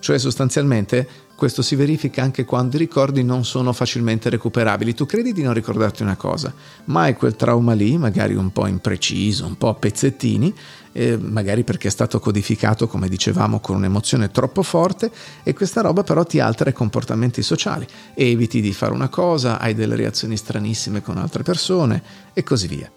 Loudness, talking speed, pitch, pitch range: -19 LUFS, 185 wpm, 120 Hz, 110-135 Hz